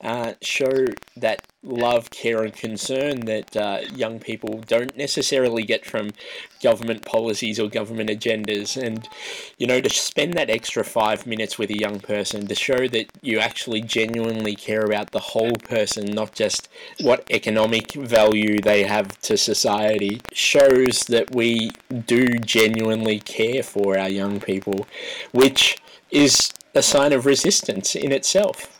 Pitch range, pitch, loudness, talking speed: 105-120 Hz, 110 Hz, -21 LUFS, 150 wpm